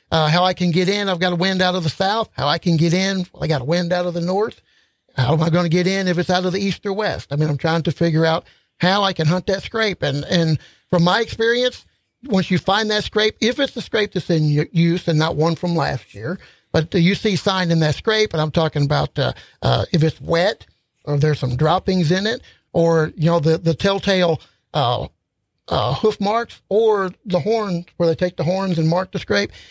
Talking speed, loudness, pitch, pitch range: 250 wpm, -19 LUFS, 180 Hz, 160-195 Hz